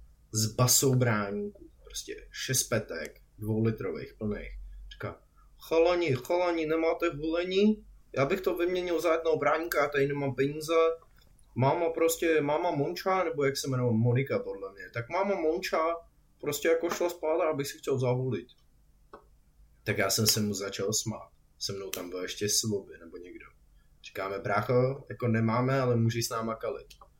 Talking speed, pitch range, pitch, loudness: 155 wpm, 110-165 Hz, 140 Hz, -29 LUFS